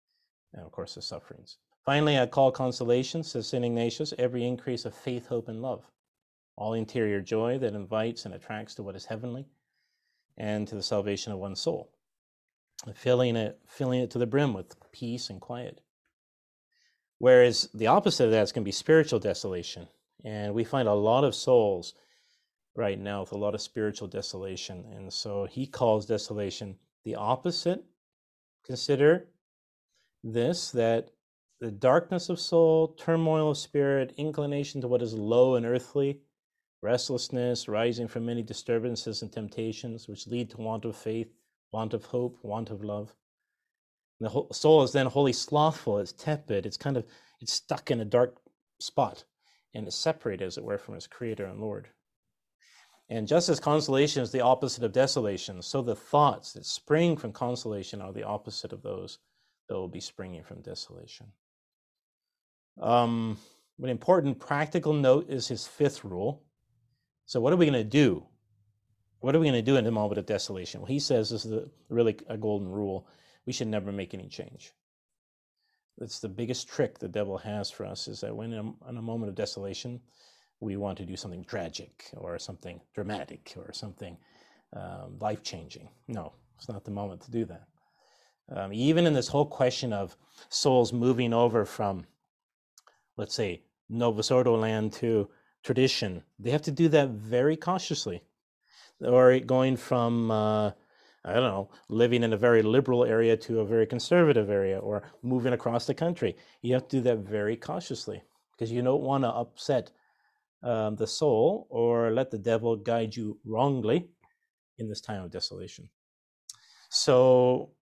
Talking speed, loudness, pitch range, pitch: 170 wpm, -28 LUFS, 105-130 Hz, 120 Hz